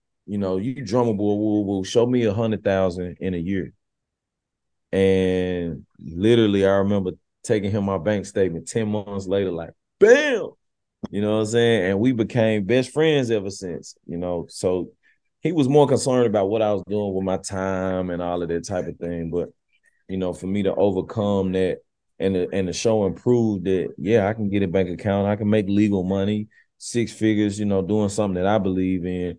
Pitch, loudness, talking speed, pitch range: 100 Hz, -22 LUFS, 200 wpm, 95-110 Hz